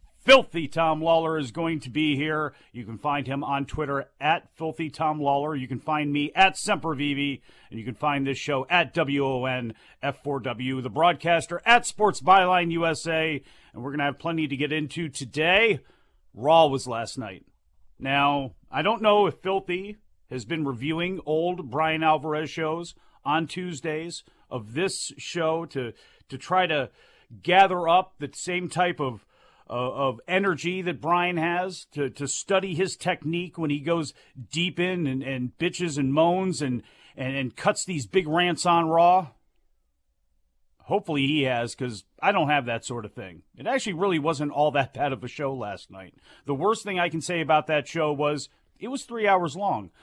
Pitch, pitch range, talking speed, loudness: 155 Hz, 135-175 Hz, 175 wpm, -25 LUFS